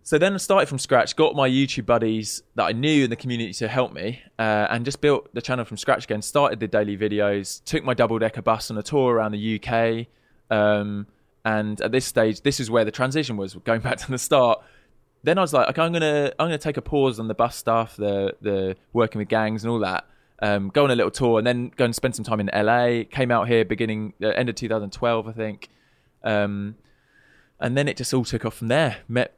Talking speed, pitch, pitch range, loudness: 245 wpm, 115 Hz, 110-130 Hz, -23 LUFS